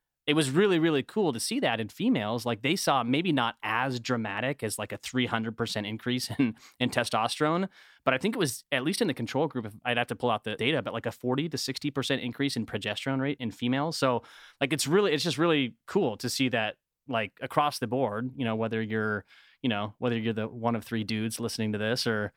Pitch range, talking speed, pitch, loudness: 110-135 Hz, 235 wpm, 120 Hz, -29 LUFS